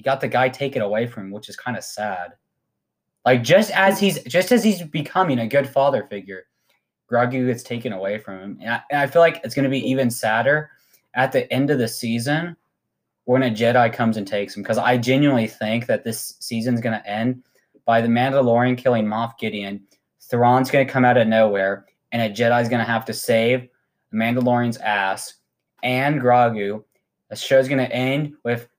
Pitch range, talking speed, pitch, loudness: 115-135 Hz, 190 wpm, 120 Hz, -20 LUFS